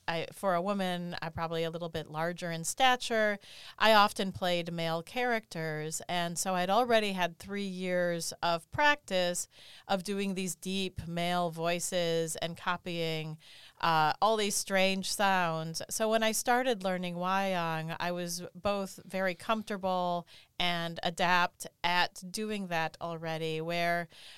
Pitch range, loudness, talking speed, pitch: 170-195 Hz, -31 LUFS, 140 wpm, 175 Hz